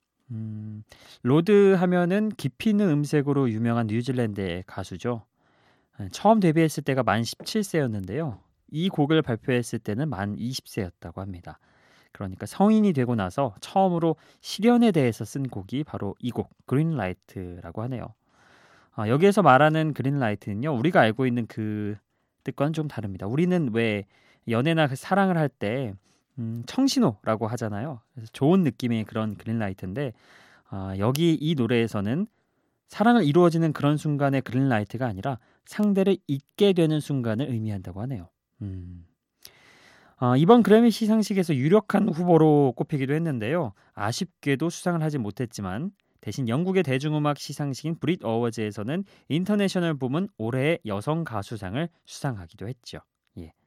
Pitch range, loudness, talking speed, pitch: 110-165 Hz, -25 LUFS, 330 characters per minute, 130 Hz